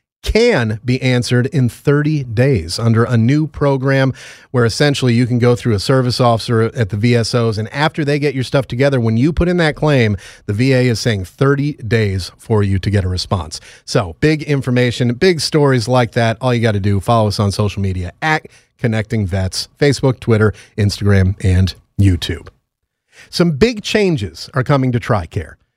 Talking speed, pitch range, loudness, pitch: 185 wpm, 105-140 Hz, -15 LUFS, 120 Hz